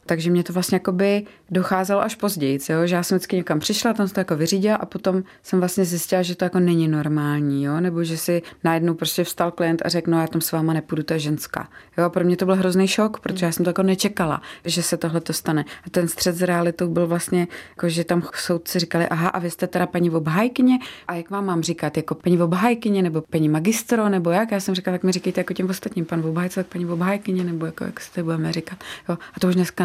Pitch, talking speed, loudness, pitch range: 175 Hz, 245 wpm, -22 LUFS, 170-190 Hz